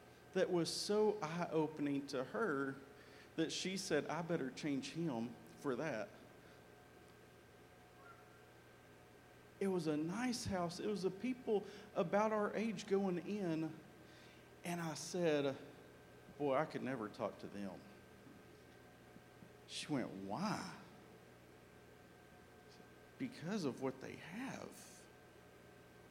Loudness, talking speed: -42 LUFS, 115 wpm